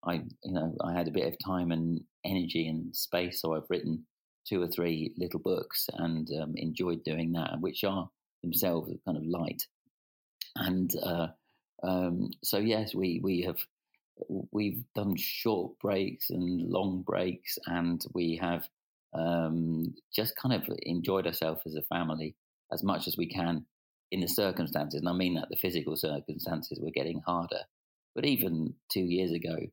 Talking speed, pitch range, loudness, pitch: 165 wpm, 80-90 Hz, -33 LUFS, 85 Hz